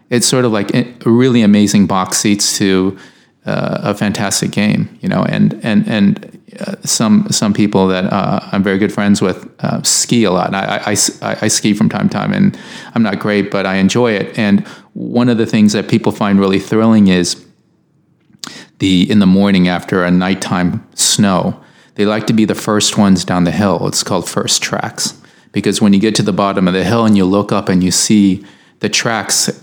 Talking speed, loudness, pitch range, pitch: 210 wpm, -13 LUFS, 95-115 Hz, 105 Hz